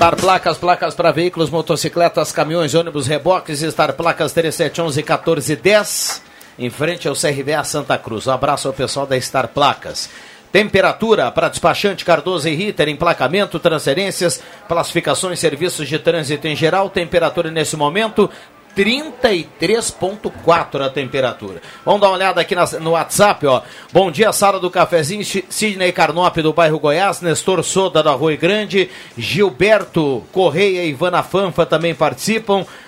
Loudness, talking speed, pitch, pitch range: -16 LUFS, 145 wpm, 170 Hz, 155-190 Hz